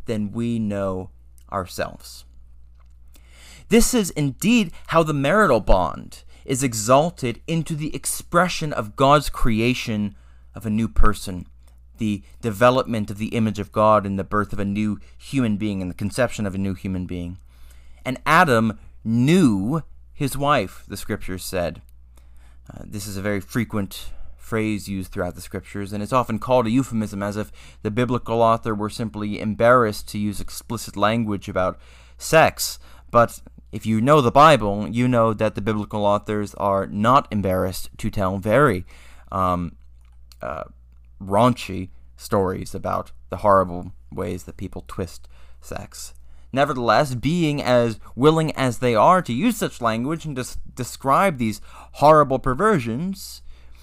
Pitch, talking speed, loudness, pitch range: 105 Hz, 150 wpm, -21 LUFS, 85-120 Hz